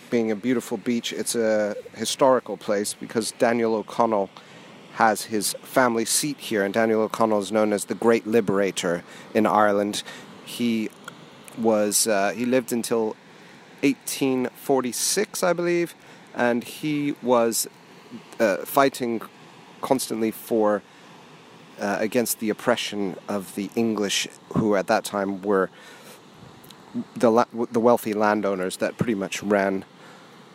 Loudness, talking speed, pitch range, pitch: -23 LUFS, 125 wpm, 105-125 Hz, 115 Hz